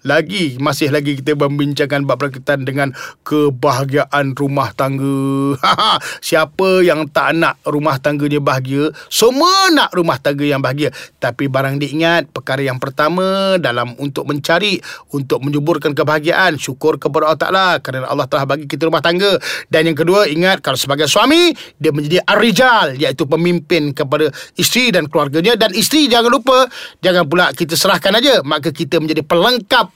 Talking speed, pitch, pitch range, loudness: 155 wpm, 155 Hz, 145-180 Hz, -14 LUFS